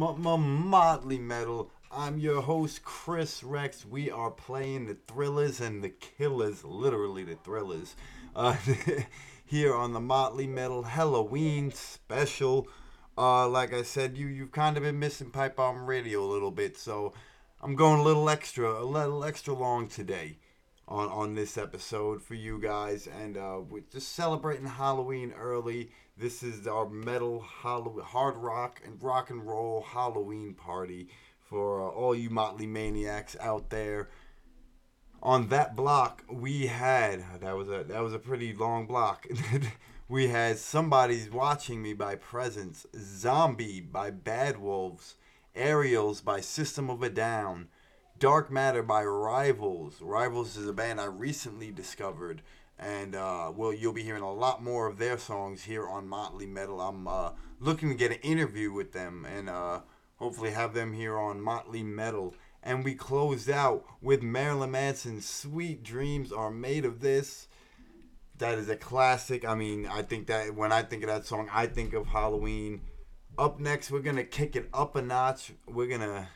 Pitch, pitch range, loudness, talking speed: 120 Hz, 110-135 Hz, -31 LUFS, 165 wpm